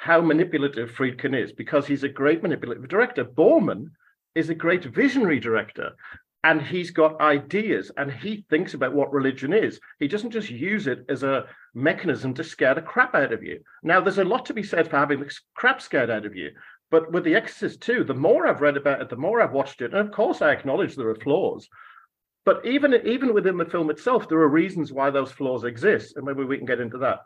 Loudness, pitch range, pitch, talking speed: -23 LUFS, 140-175 Hz, 150 Hz, 225 wpm